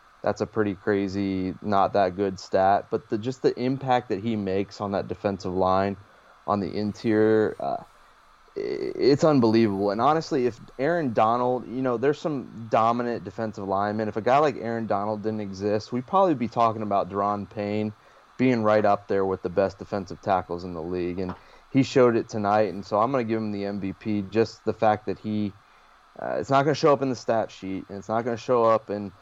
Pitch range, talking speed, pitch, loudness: 100-115 Hz, 210 wpm, 105 Hz, -25 LUFS